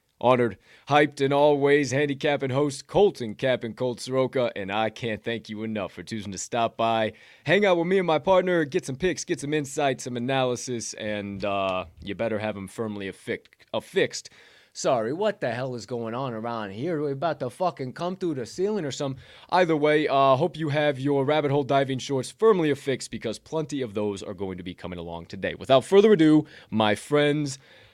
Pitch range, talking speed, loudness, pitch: 110-150 Hz, 205 wpm, -25 LUFS, 130 Hz